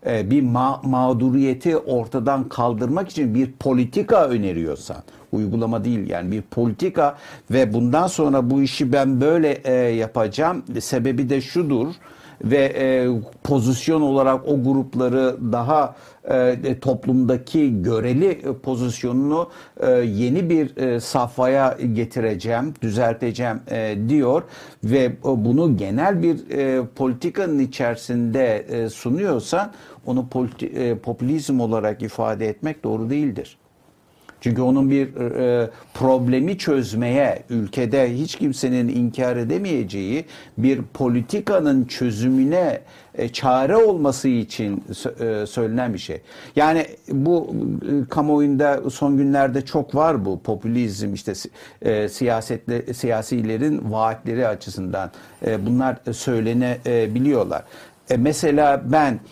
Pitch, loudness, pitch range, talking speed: 125 Hz, -21 LUFS, 115-140 Hz, 110 wpm